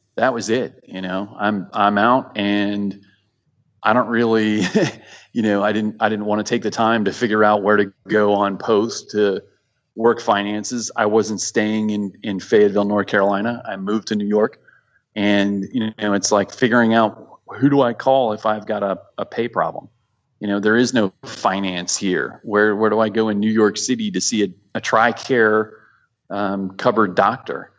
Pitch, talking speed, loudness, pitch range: 105 Hz, 190 wpm, -19 LUFS, 100-110 Hz